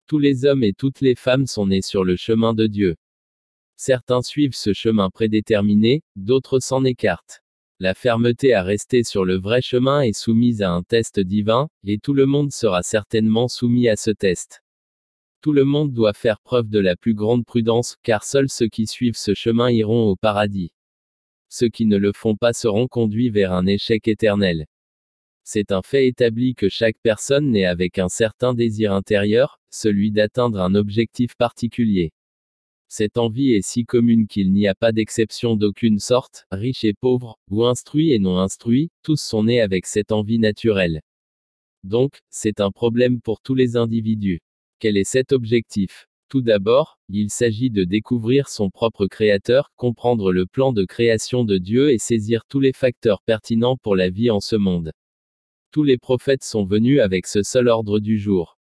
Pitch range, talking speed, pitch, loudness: 100-125 Hz, 180 wpm, 110 Hz, -19 LUFS